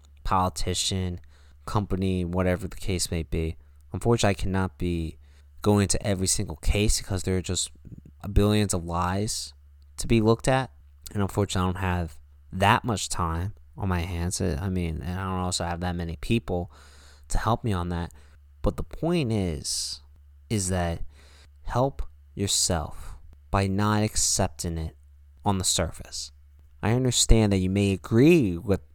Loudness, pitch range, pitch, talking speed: -26 LUFS, 75-100 Hz, 90 Hz, 155 wpm